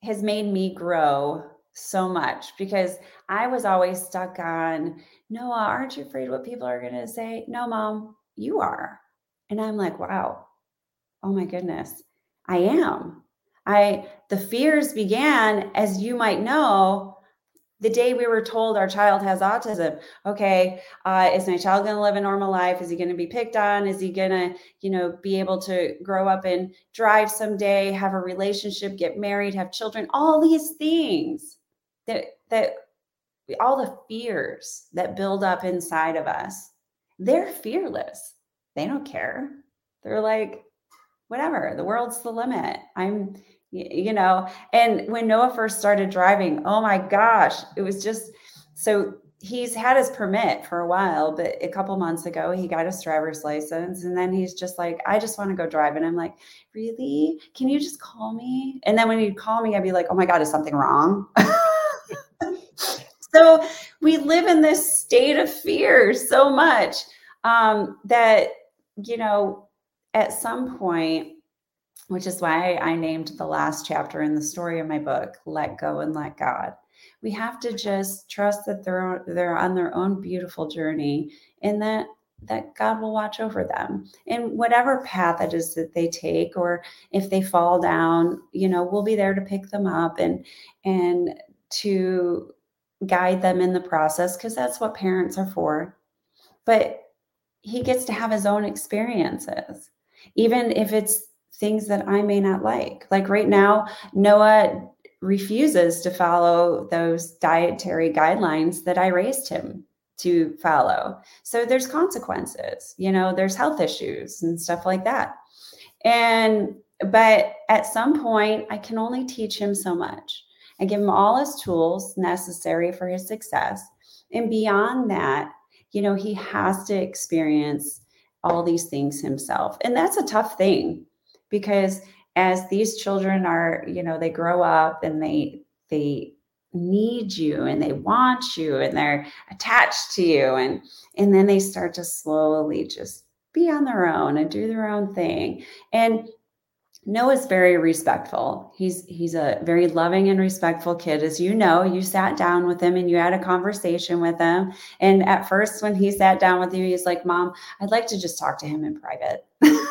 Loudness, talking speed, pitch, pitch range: -22 LUFS, 170 wpm, 195 Hz, 175-225 Hz